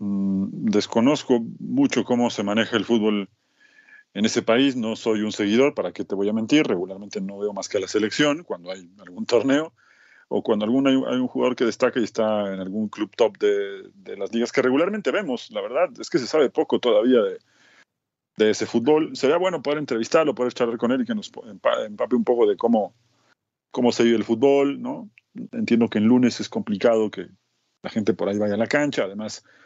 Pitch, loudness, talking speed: 125 Hz, -22 LUFS, 210 wpm